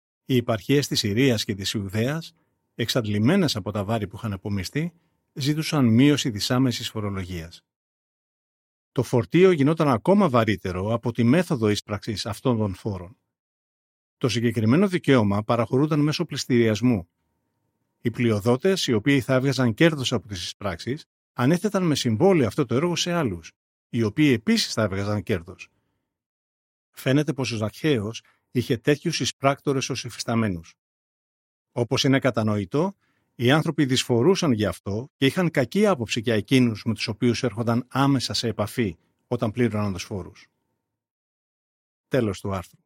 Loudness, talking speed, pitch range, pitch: -23 LUFS, 135 wpm, 105-140 Hz, 120 Hz